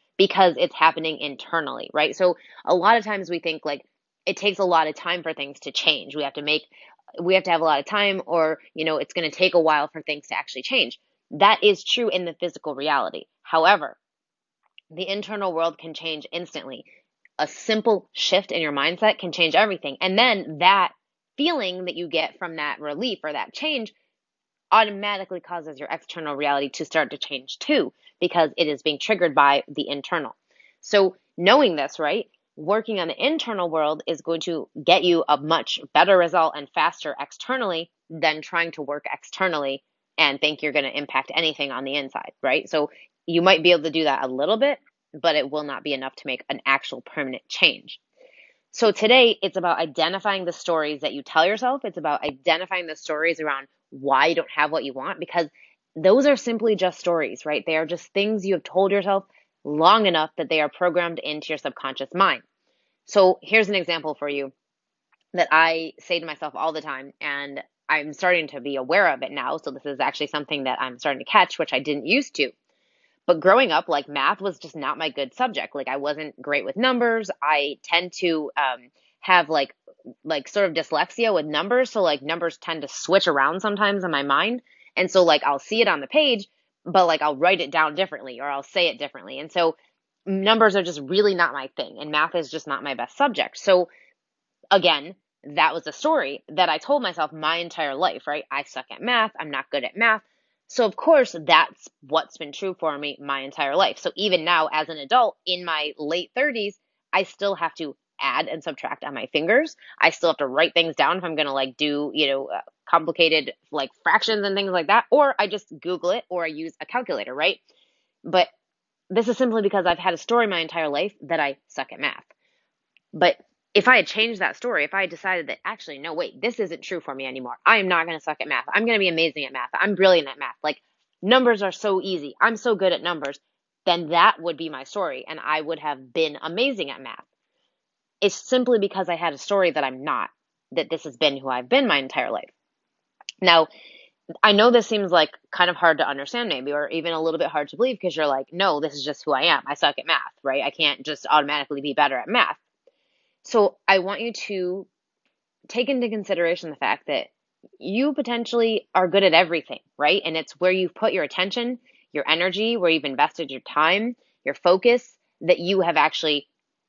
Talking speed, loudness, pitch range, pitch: 215 wpm, -22 LUFS, 150-200 Hz, 170 Hz